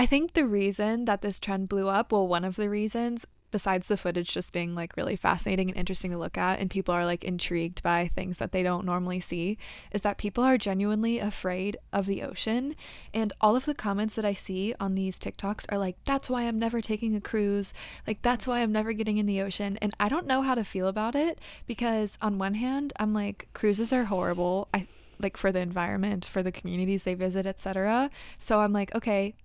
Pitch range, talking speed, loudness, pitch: 190-220 Hz, 225 wpm, -29 LUFS, 205 Hz